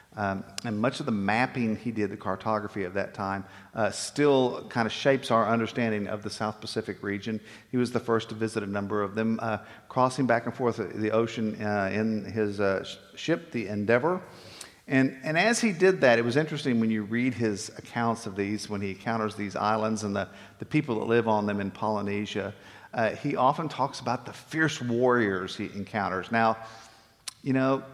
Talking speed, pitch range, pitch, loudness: 200 wpm, 105-125 Hz, 110 Hz, -28 LUFS